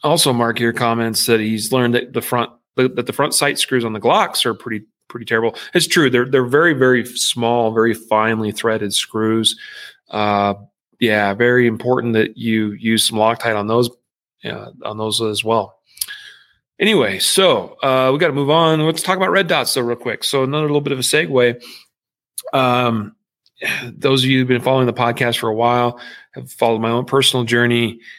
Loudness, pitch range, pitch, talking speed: -16 LUFS, 110-130 Hz, 120 Hz, 190 wpm